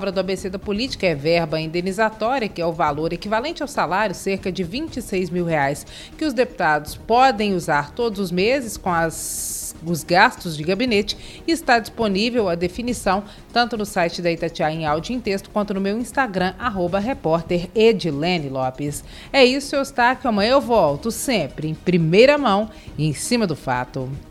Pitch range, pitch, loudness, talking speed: 165-235 Hz, 195 Hz, -21 LUFS, 180 wpm